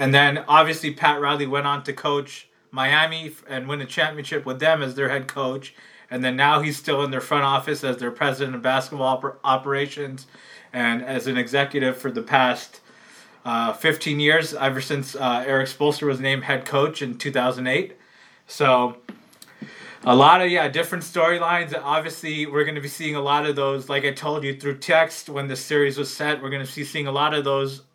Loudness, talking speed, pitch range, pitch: -22 LUFS, 200 wpm, 135-150 Hz, 140 Hz